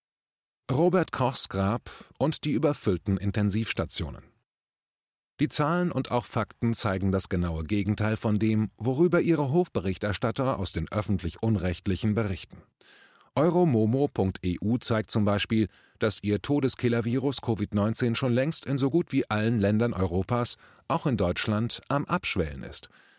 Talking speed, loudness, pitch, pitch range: 125 wpm, -27 LUFS, 115 Hz, 100-135 Hz